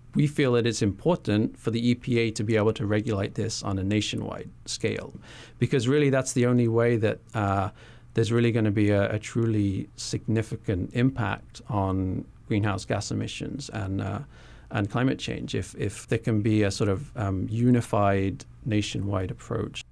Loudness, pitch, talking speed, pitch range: -27 LUFS, 110 Hz, 170 wpm, 105-120 Hz